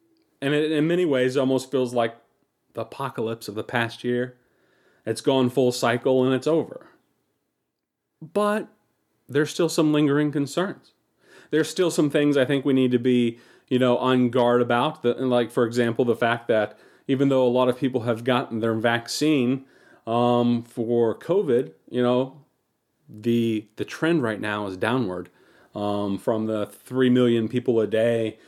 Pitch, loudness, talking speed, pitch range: 125 Hz, -23 LUFS, 170 wpm, 115-140 Hz